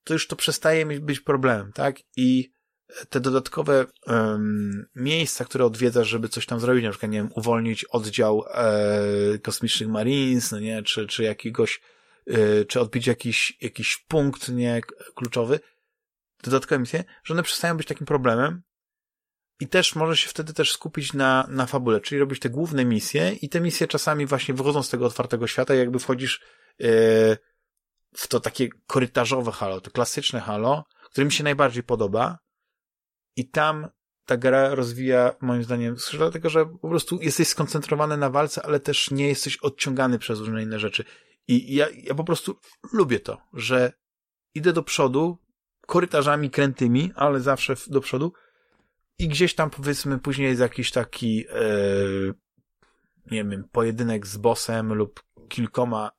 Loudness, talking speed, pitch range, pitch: -24 LUFS, 155 wpm, 115-150 Hz, 130 Hz